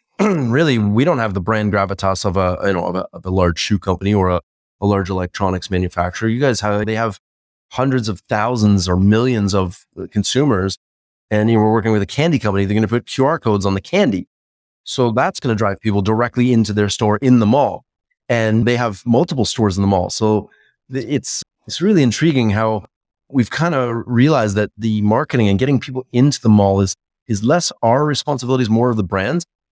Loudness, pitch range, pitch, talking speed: -17 LUFS, 95-125 Hz, 110 Hz, 210 wpm